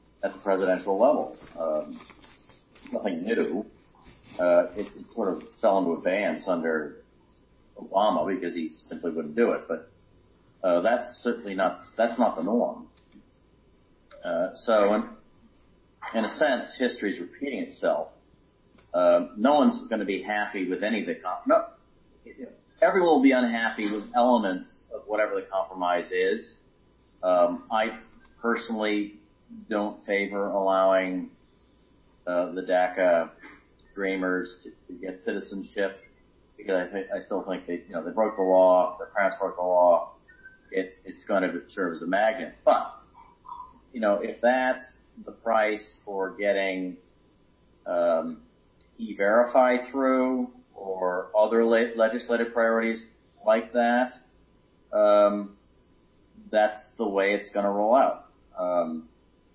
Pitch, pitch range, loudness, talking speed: 110 Hz, 95-130 Hz, -26 LUFS, 140 wpm